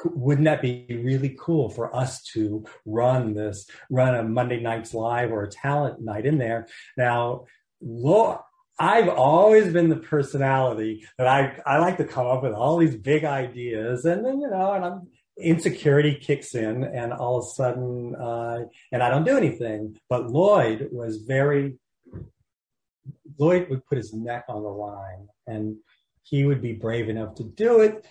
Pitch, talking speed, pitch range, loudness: 125 Hz, 175 wpm, 115-150 Hz, -23 LUFS